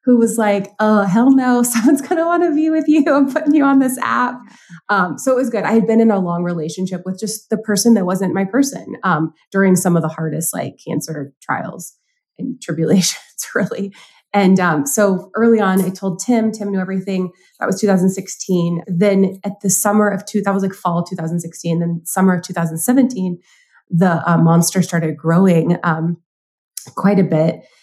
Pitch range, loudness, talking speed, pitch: 175-225 Hz, -16 LUFS, 195 wpm, 195 Hz